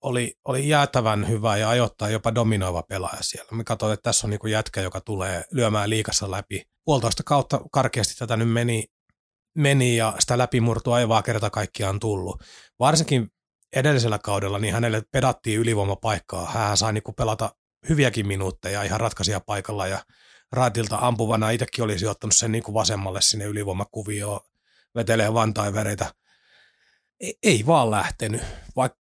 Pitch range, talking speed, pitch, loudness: 105-120 Hz, 145 wpm, 110 Hz, -23 LUFS